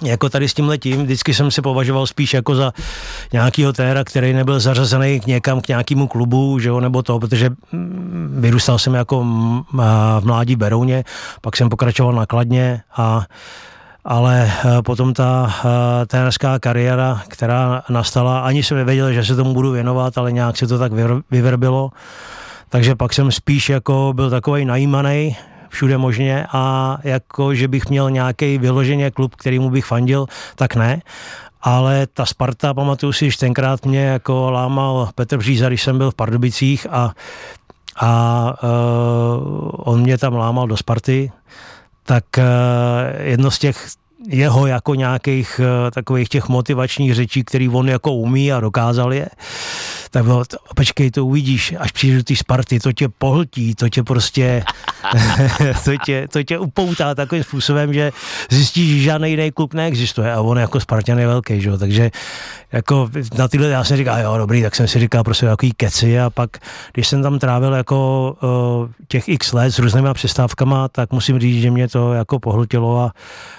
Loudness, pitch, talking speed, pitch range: -16 LUFS, 130 Hz, 165 wpm, 120-135 Hz